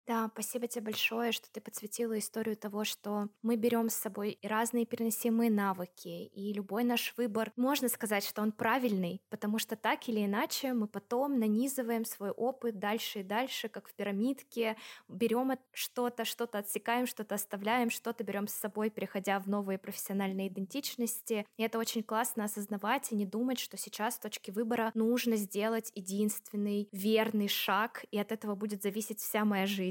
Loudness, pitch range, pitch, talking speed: -34 LUFS, 205-235 Hz, 220 Hz, 165 wpm